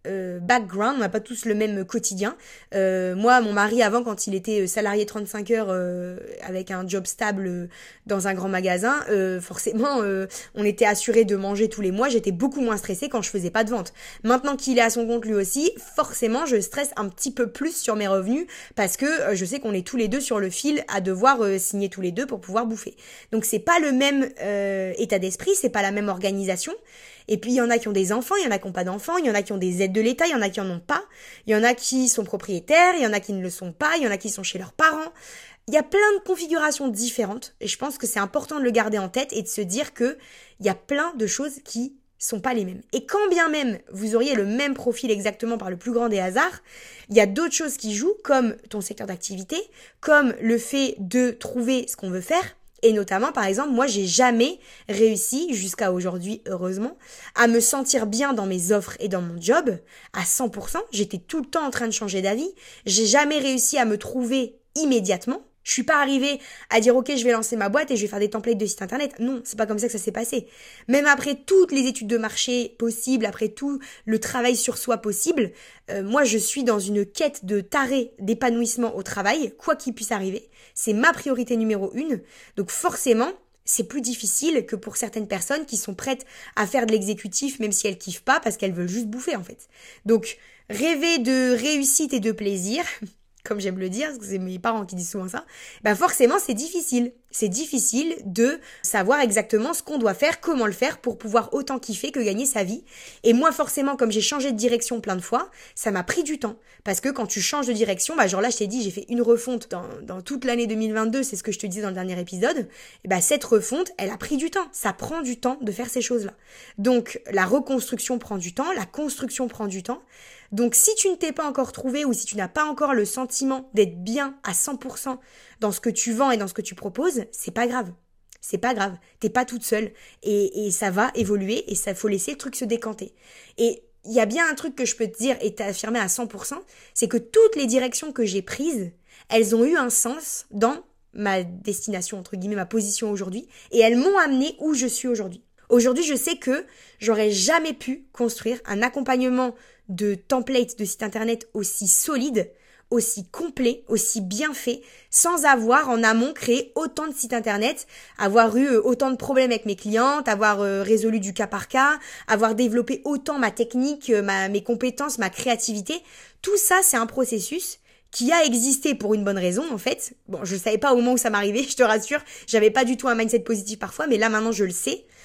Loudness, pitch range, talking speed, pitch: -23 LUFS, 210-265 Hz, 235 wpm, 230 Hz